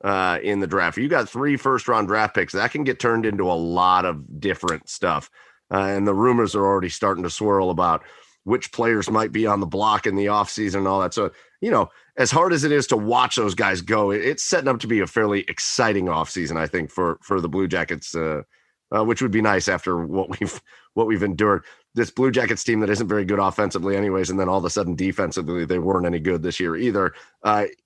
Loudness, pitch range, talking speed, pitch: -22 LUFS, 90-110 Hz, 235 wpm, 100 Hz